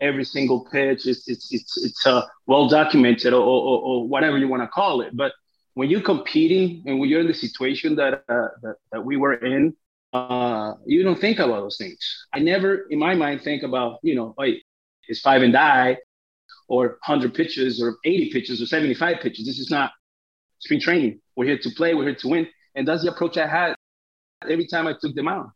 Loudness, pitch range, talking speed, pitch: -21 LUFS, 125-165 Hz, 215 wpm, 140 Hz